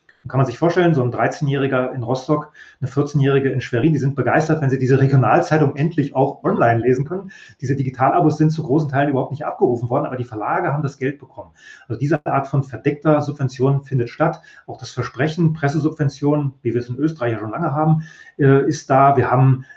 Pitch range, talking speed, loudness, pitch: 130-150 Hz, 205 wpm, -19 LUFS, 140 Hz